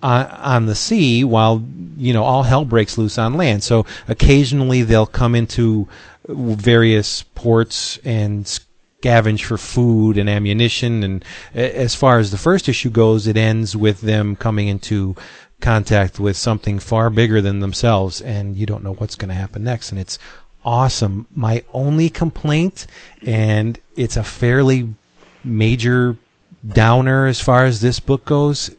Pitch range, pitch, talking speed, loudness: 105-125 Hz, 115 Hz, 155 wpm, -16 LUFS